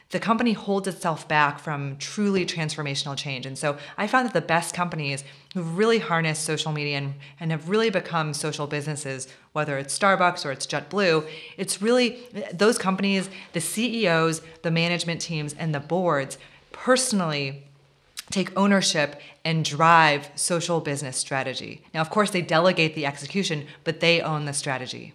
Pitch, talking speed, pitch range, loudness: 160 Hz, 155 wpm, 145-185 Hz, -24 LUFS